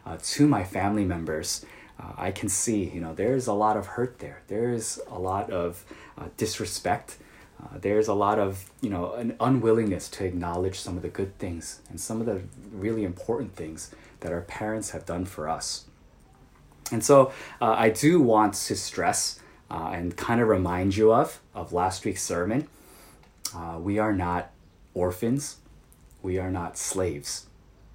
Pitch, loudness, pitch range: 100 Hz, -27 LUFS, 90-110 Hz